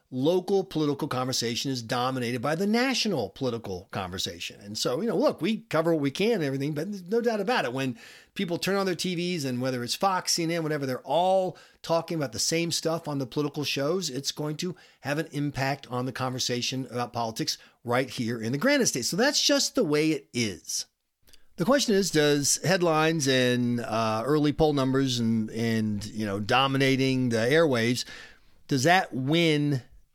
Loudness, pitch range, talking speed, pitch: -26 LUFS, 125-170 Hz, 190 wpm, 145 Hz